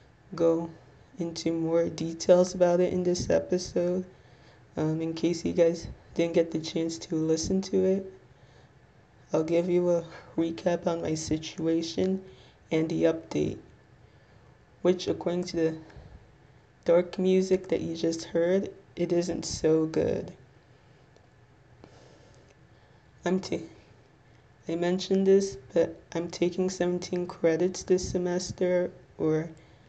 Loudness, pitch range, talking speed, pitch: -28 LUFS, 140-180 Hz, 120 wpm, 165 Hz